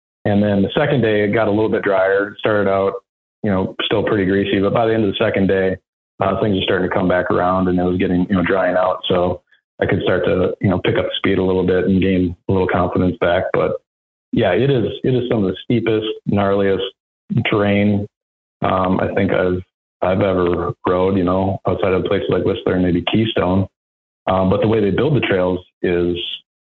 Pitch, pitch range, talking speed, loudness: 95 Hz, 90-105 Hz, 225 wpm, -17 LUFS